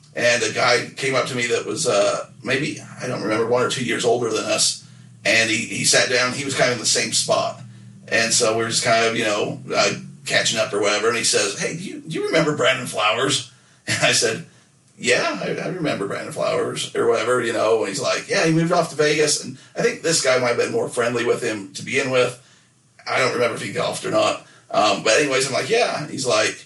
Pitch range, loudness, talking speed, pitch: 125-165 Hz, -20 LUFS, 250 wpm, 135 Hz